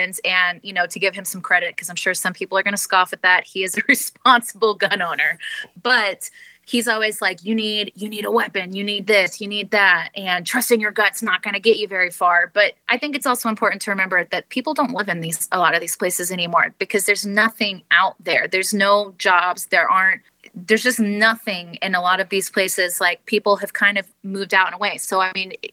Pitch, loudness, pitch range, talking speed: 200 Hz, -18 LUFS, 185-220 Hz, 245 wpm